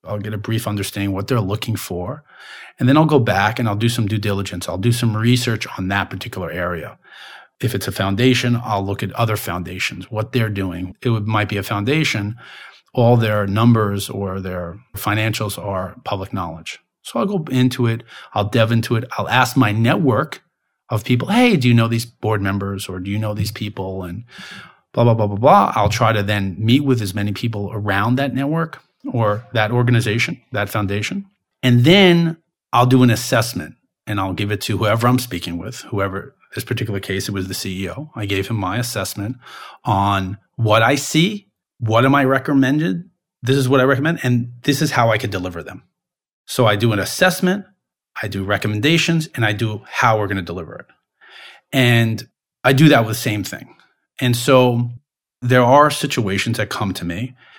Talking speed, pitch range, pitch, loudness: 195 wpm, 100-125 Hz, 110 Hz, -18 LUFS